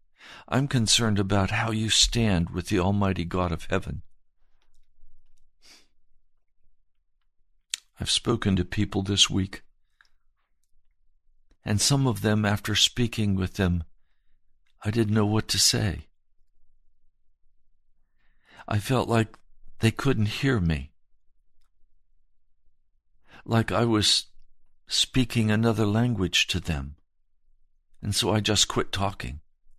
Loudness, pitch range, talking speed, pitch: -24 LUFS, 85-110 Hz, 105 wpm, 100 Hz